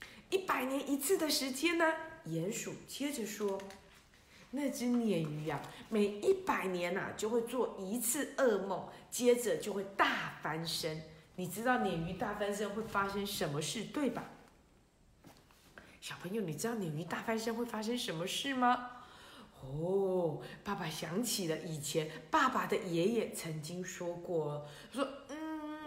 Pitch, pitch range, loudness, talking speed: 200 Hz, 175-245 Hz, -36 LUFS, 215 characters per minute